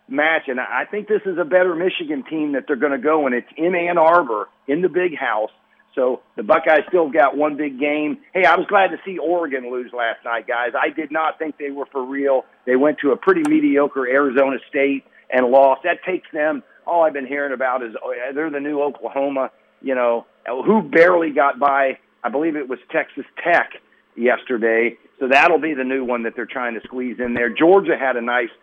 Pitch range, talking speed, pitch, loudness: 130-175 Hz, 220 wpm, 145 Hz, -19 LUFS